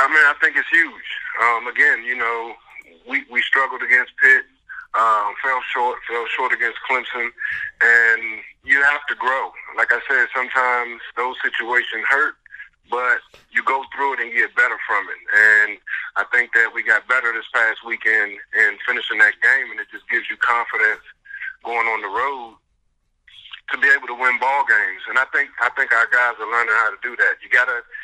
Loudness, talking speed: -18 LUFS, 195 wpm